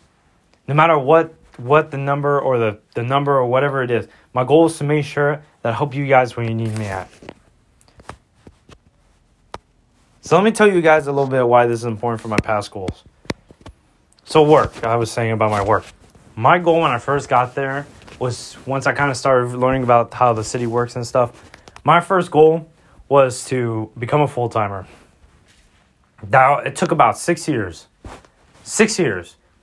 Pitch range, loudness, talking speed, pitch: 115-145 Hz, -17 LUFS, 185 wpm, 125 Hz